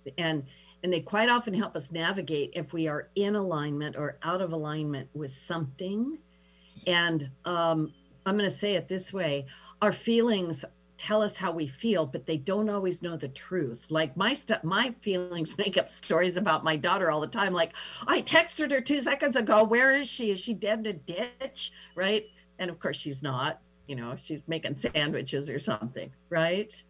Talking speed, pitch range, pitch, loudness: 190 wpm, 155-210 Hz, 175 Hz, -29 LUFS